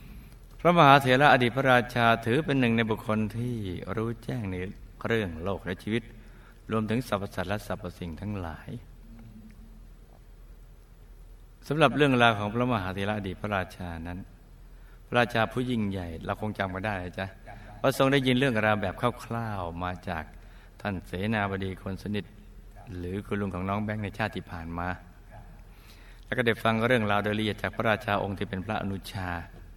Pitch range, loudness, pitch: 95-115 Hz, -28 LUFS, 105 Hz